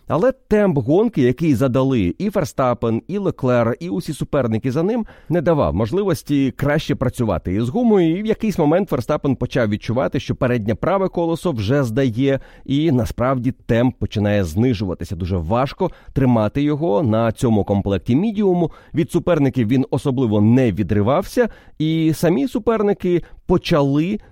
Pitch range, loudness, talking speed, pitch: 120-170 Hz, -19 LUFS, 140 wpm, 140 Hz